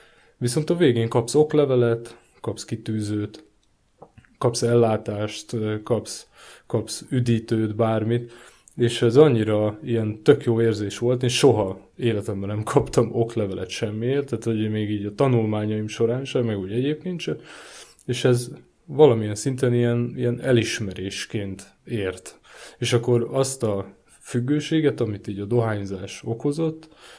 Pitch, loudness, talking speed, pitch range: 115 Hz, -23 LUFS, 130 wpm, 105-125 Hz